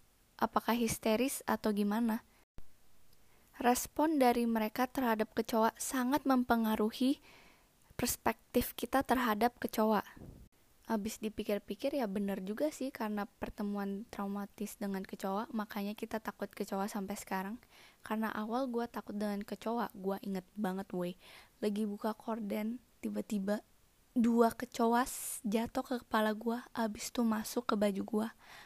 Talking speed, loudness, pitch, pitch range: 120 wpm, -35 LUFS, 220 Hz, 205-235 Hz